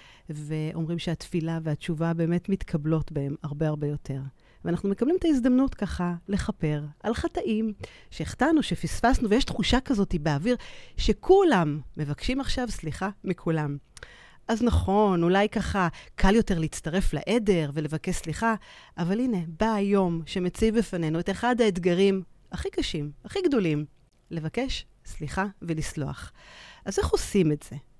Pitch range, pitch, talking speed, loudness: 155-220 Hz, 180 Hz, 125 wpm, -27 LUFS